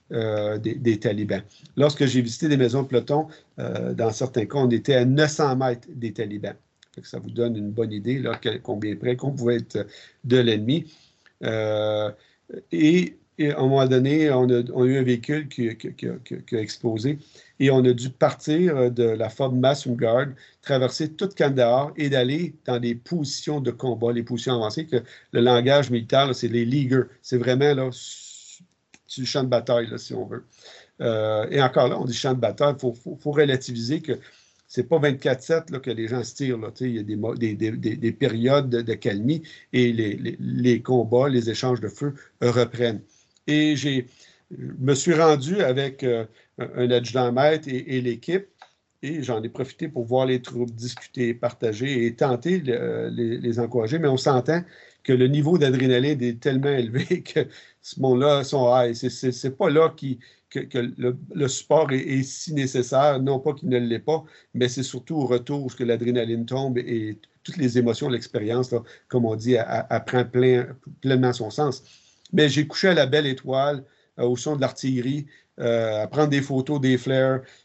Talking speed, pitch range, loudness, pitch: 195 wpm, 120-145 Hz, -23 LUFS, 125 Hz